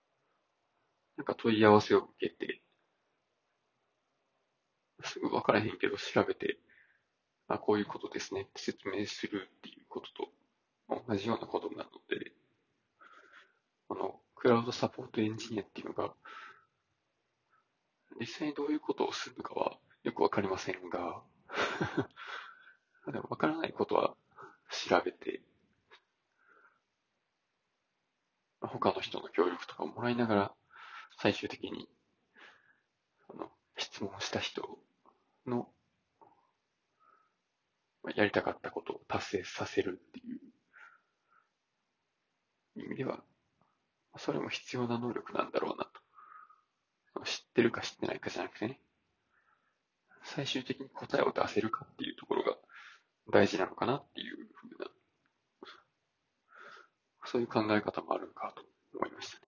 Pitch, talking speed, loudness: 380 Hz, 245 characters per minute, -35 LUFS